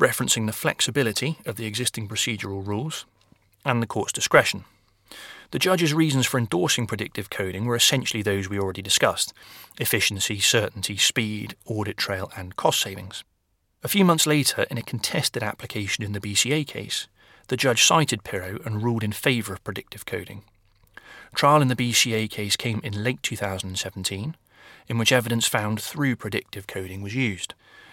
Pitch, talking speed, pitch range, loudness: 110 Hz, 160 wpm, 100-125 Hz, -23 LUFS